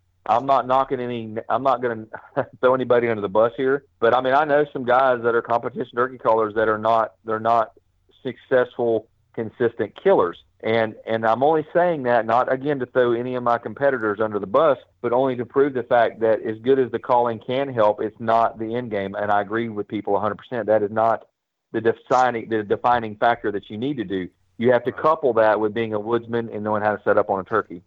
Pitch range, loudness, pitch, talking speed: 110-125 Hz, -21 LUFS, 115 Hz, 225 wpm